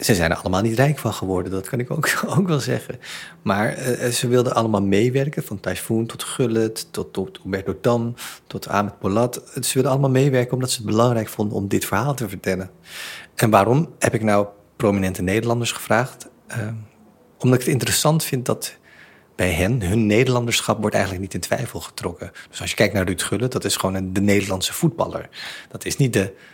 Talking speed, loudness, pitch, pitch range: 200 wpm, -21 LUFS, 115 Hz, 100-125 Hz